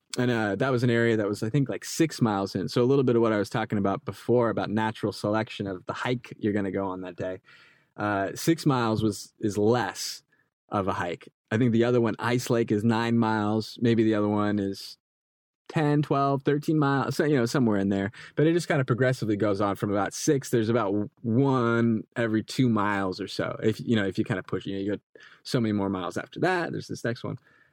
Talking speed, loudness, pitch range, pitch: 245 wpm, -26 LUFS, 105-125 Hz, 110 Hz